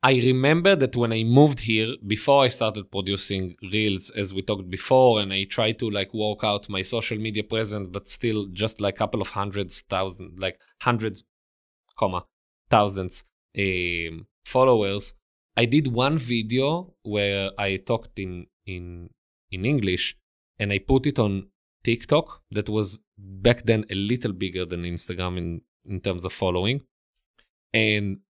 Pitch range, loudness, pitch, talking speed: 95-115 Hz, -24 LUFS, 105 Hz, 155 wpm